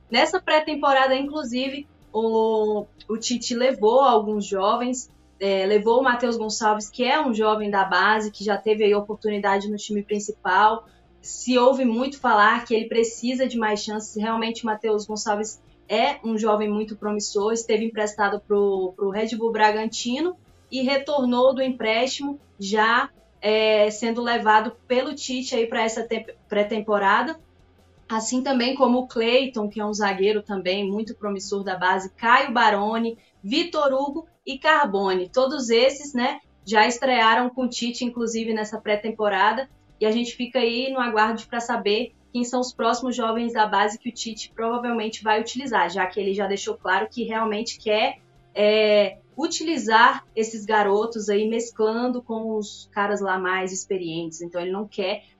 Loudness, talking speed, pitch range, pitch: -22 LUFS, 160 wpm, 210-245 Hz, 220 Hz